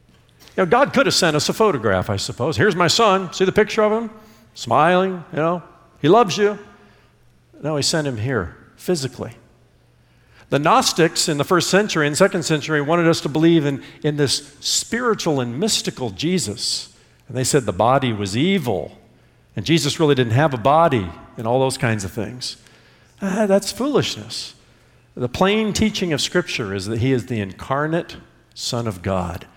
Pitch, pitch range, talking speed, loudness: 145 Hz, 120-180 Hz, 180 wpm, -19 LUFS